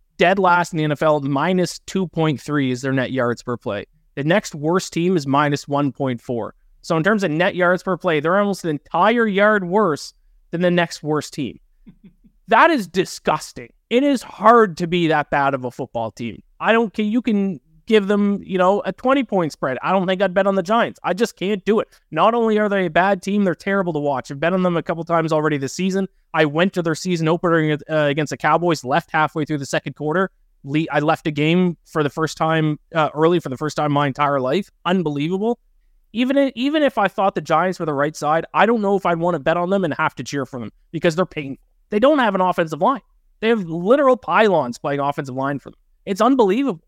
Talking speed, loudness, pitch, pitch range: 235 wpm, -19 LUFS, 175 Hz, 150-200 Hz